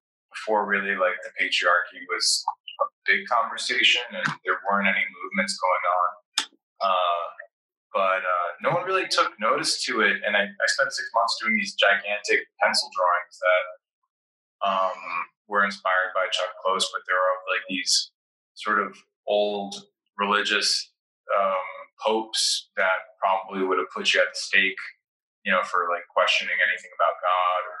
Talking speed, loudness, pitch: 160 wpm, -24 LUFS, 100 Hz